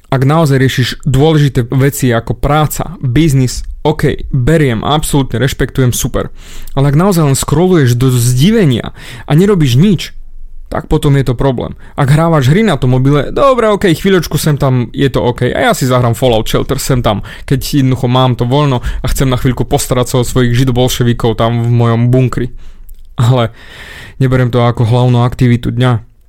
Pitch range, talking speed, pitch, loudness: 125-145 Hz, 170 wpm, 130 Hz, -11 LUFS